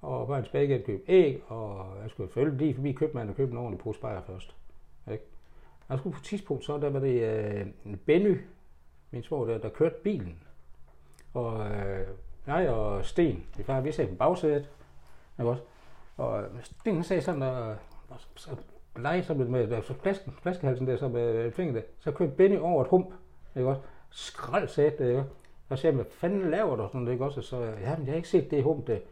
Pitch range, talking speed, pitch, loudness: 105-150 Hz, 210 wpm, 125 Hz, -30 LUFS